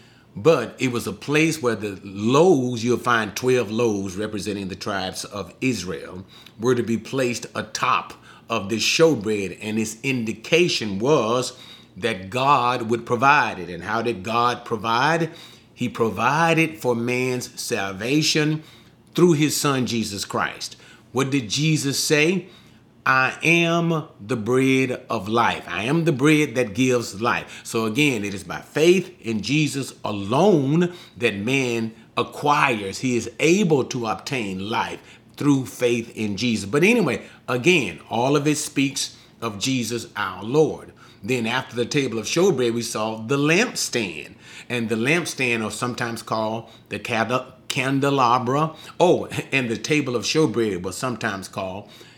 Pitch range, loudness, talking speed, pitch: 110-140 Hz, -22 LUFS, 145 wpm, 120 Hz